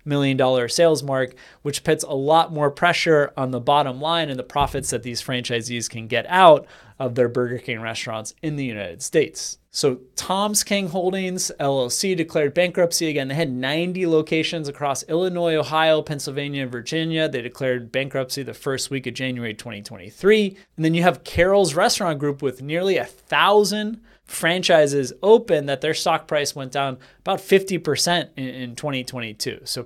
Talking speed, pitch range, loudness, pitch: 165 wpm, 130-170 Hz, -21 LUFS, 145 Hz